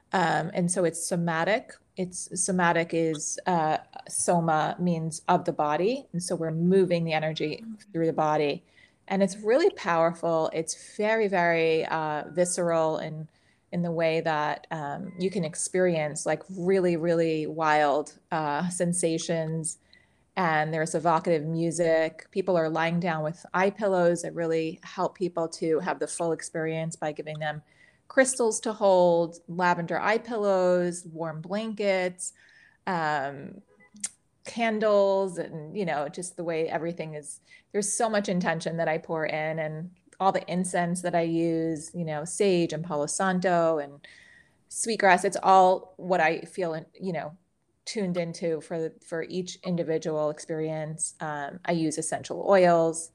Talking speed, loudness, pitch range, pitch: 150 wpm, -27 LUFS, 160-185 Hz, 170 Hz